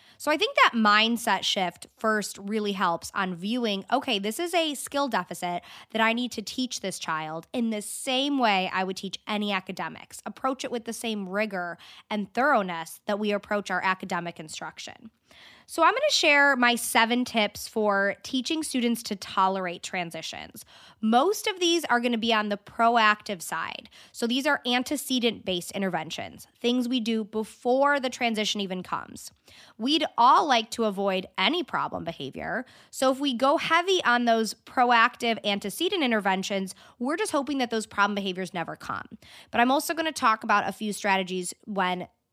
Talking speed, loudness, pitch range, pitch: 170 wpm, -26 LUFS, 195-250 Hz, 220 Hz